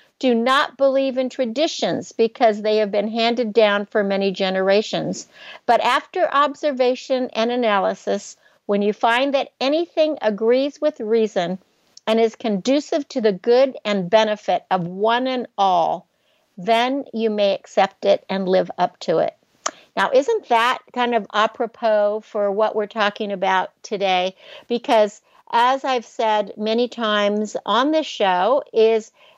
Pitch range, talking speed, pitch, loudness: 205-260 Hz, 145 wpm, 225 Hz, -20 LUFS